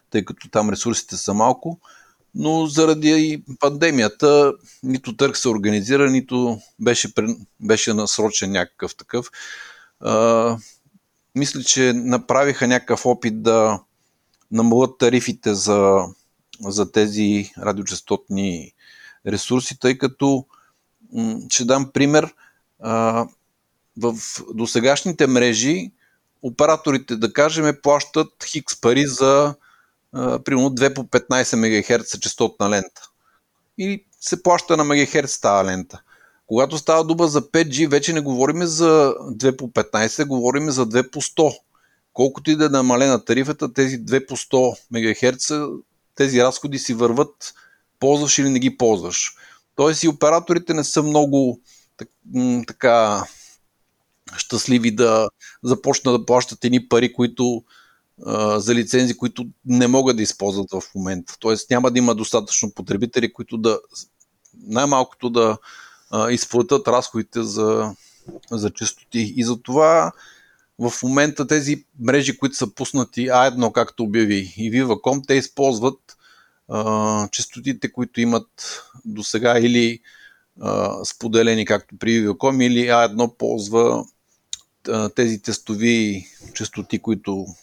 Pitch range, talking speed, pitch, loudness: 110-140 Hz, 120 wpm, 125 Hz, -19 LUFS